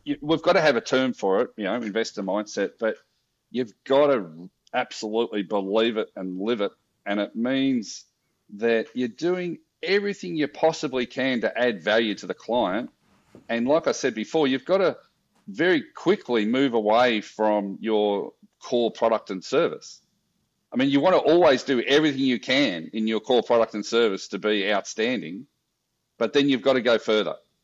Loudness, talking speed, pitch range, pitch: -24 LUFS, 180 wpm, 110-160 Hz, 125 Hz